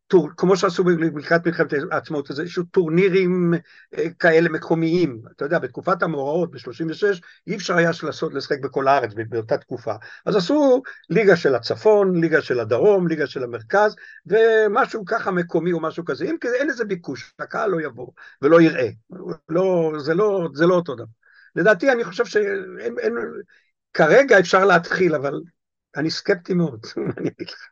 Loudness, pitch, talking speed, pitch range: -20 LUFS, 175 Hz, 150 wpm, 160-210 Hz